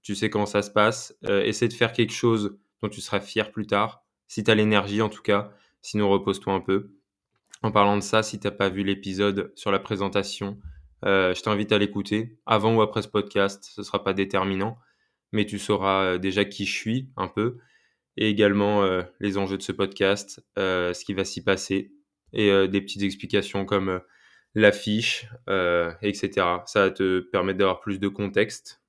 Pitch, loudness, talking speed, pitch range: 100 Hz, -25 LUFS, 200 wpm, 95-105 Hz